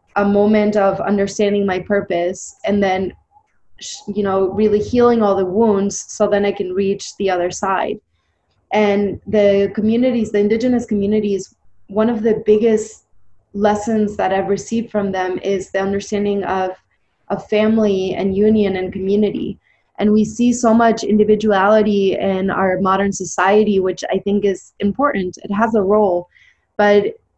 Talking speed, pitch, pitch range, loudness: 150 wpm, 200 Hz, 190-215 Hz, -17 LUFS